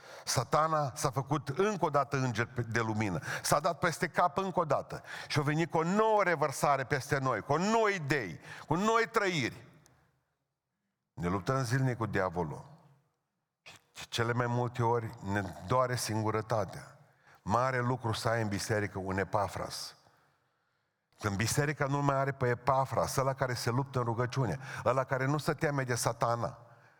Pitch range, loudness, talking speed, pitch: 115-150 Hz, -32 LUFS, 160 wpm, 135 Hz